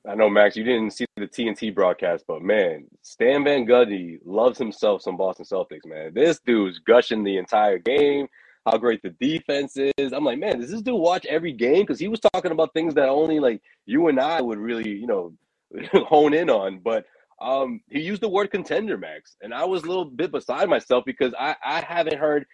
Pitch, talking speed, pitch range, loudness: 145 Hz, 215 wpm, 115-185 Hz, -22 LUFS